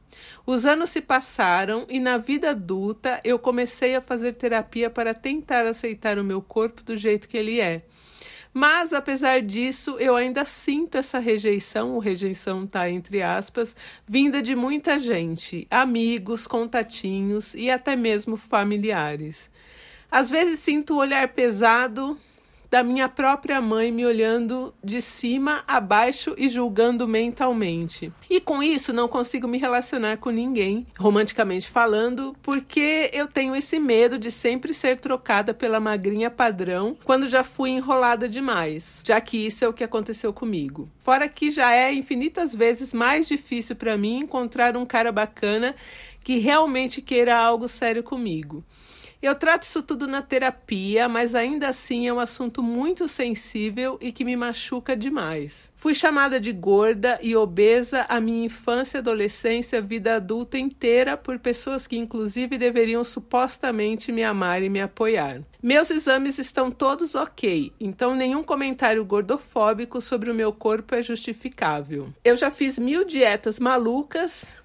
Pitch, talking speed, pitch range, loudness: 245 Hz, 150 wpm, 225-265 Hz, -23 LUFS